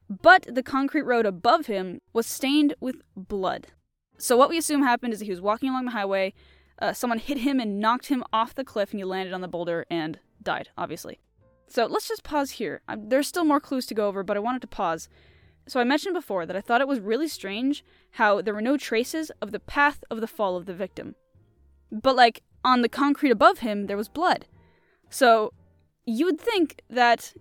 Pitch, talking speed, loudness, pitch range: 235 Hz, 220 wpm, -25 LUFS, 200-280 Hz